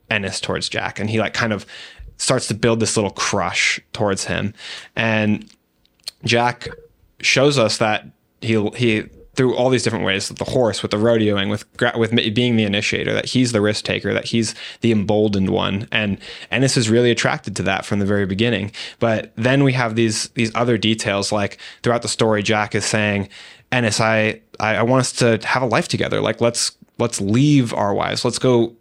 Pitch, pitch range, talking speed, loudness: 110 Hz, 105-120 Hz, 195 wpm, -19 LUFS